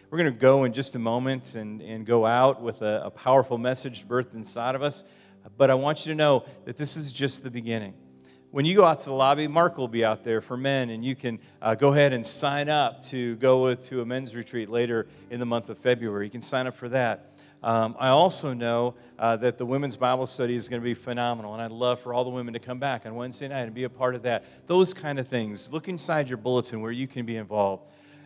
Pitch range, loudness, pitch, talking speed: 115-135 Hz, -26 LUFS, 125 Hz, 255 wpm